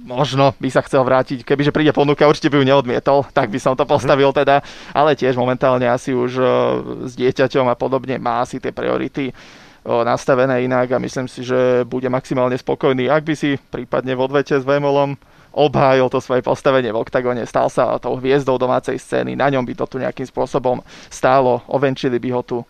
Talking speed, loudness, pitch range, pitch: 190 wpm, -17 LUFS, 125-140 Hz, 130 Hz